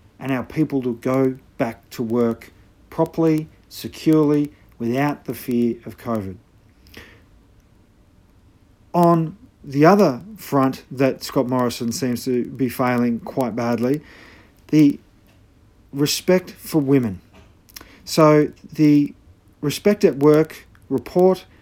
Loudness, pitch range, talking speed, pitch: -20 LUFS, 105-150 Hz, 105 wpm, 125 Hz